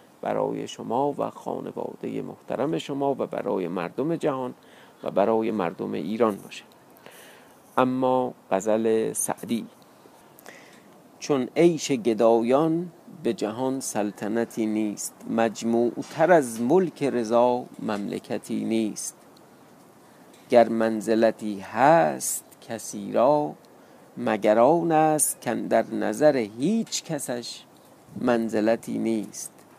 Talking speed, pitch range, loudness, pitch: 95 wpm, 110-140 Hz, -25 LUFS, 120 Hz